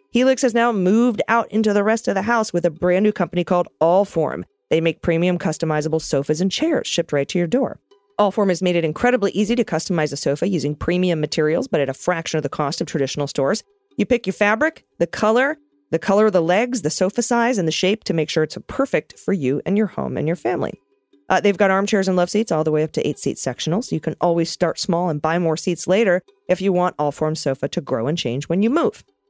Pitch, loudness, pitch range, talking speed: 180 Hz, -20 LUFS, 160-210 Hz, 245 wpm